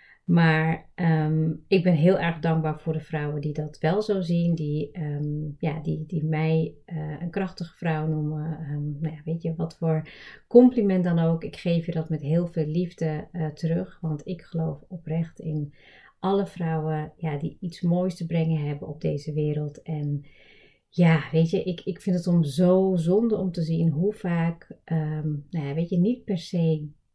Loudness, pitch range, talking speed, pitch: -26 LUFS, 155-175 Hz, 190 wpm, 160 Hz